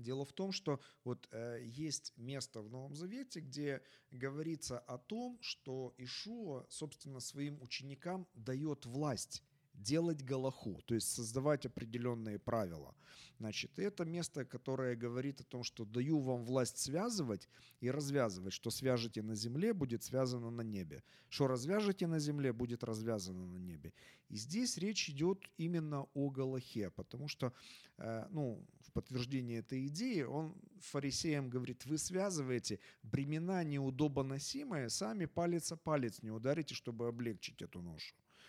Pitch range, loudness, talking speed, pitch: 120-155 Hz, -41 LUFS, 140 wpm, 135 Hz